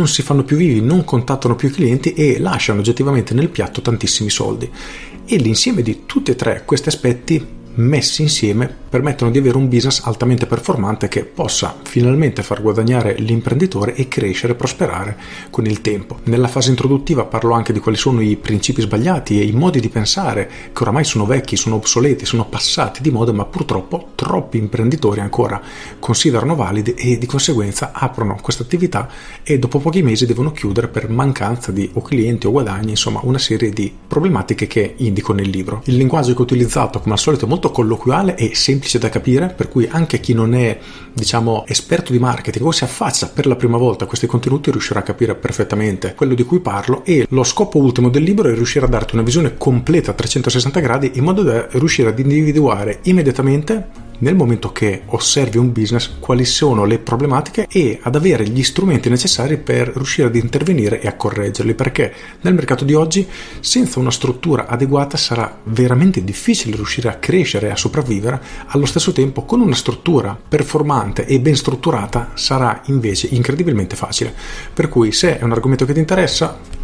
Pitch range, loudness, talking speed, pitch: 115-140 Hz, -16 LUFS, 185 wpm, 125 Hz